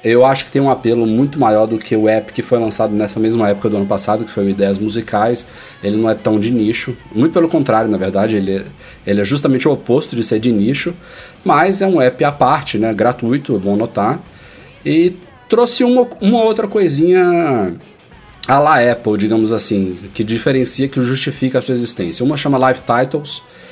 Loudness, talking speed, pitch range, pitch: -14 LUFS, 200 wpm, 110-145 Hz, 120 Hz